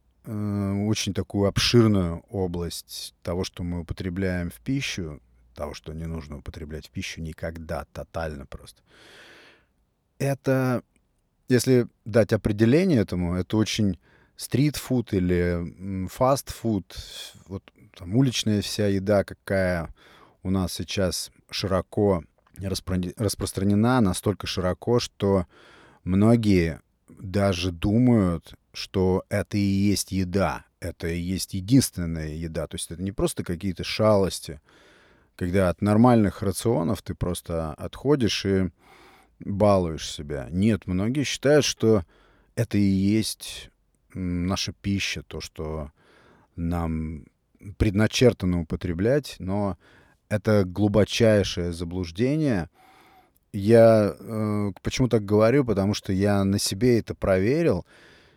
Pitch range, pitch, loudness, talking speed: 85-110 Hz, 95 Hz, -24 LUFS, 110 wpm